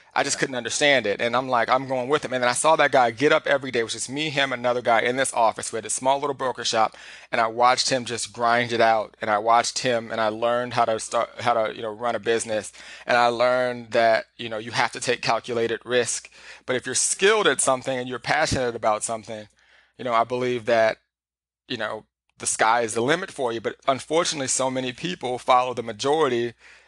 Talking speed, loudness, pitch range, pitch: 240 wpm, -23 LUFS, 115-130 Hz, 120 Hz